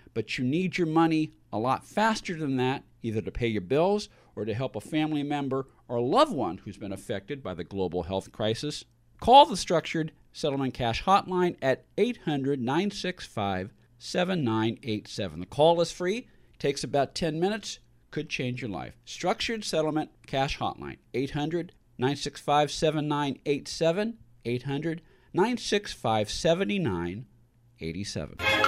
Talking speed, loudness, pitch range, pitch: 135 wpm, -28 LUFS, 115-165 Hz, 135 Hz